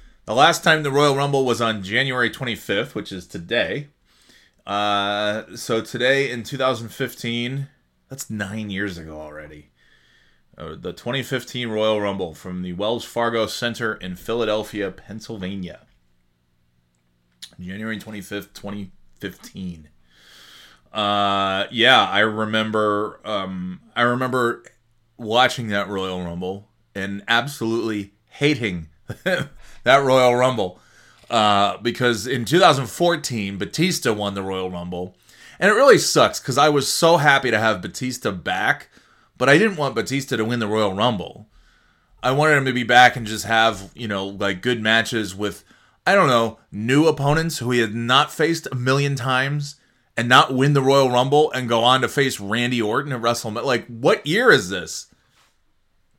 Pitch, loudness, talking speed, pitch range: 115 Hz, -20 LUFS, 150 wpm, 100-130 Hz